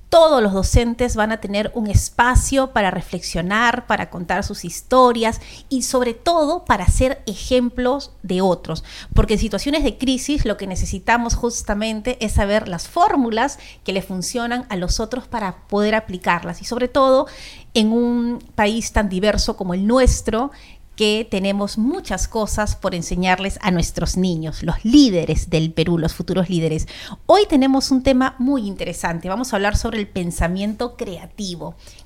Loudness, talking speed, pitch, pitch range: -19 LUFS, 155 wpm, 215 Hz, 185-250 Hz